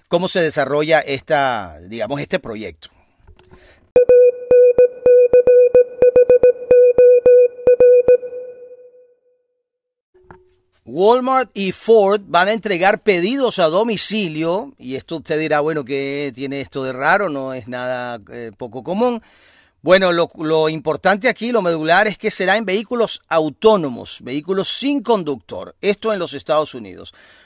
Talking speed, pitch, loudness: 115 wpm, 205 Hz, -15 LUFS